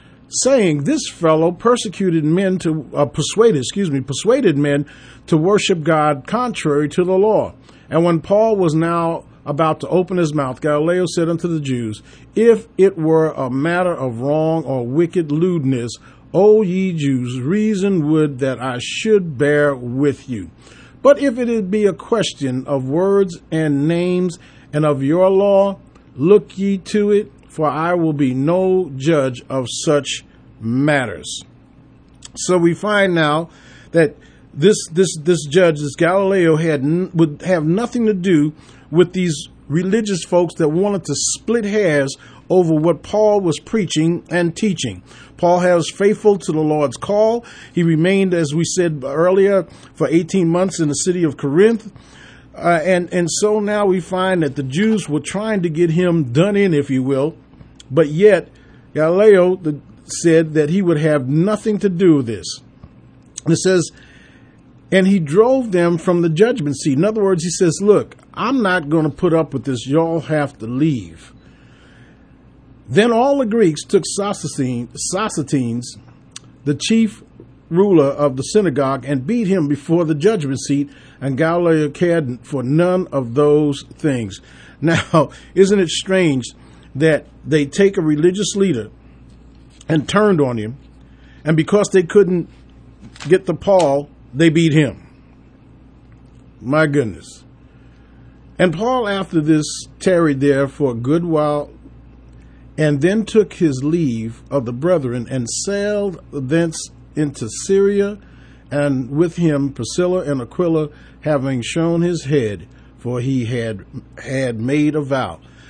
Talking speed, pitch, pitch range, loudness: 150 wpm, 160 Hz, 140-185 Hz, -17 LUFS